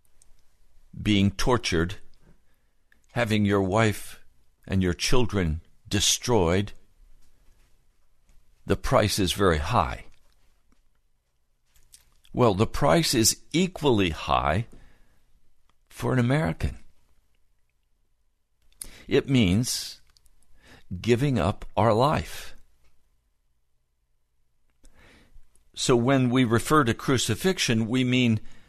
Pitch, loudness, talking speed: 90 Hz, -24 LUFS, 75 wpm